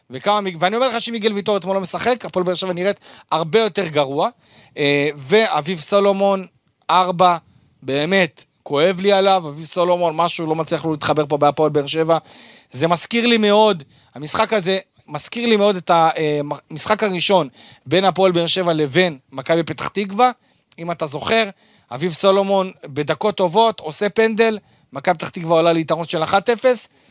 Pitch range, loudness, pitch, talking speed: 155-205 Hz, -18 LUFS, 180 Hz, 155 wpm